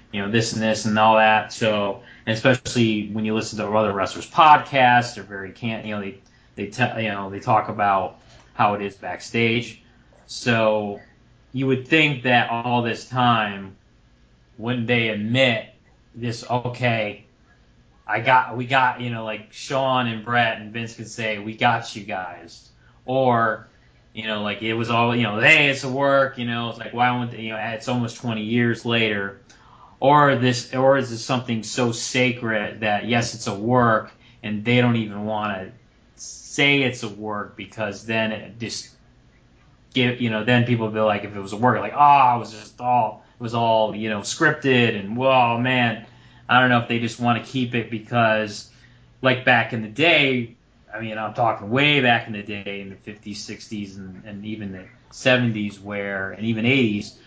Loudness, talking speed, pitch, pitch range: -21 LUFS, 195 wpm, 115 Hz, 105-125 Hz